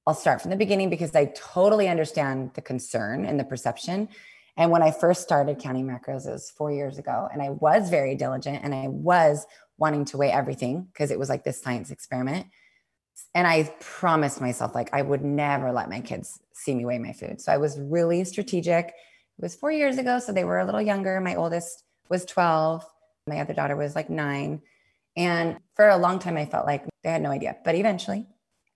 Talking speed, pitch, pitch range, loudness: 210 wpm, 160 Hz, 140-180 Hz, -25 LUFS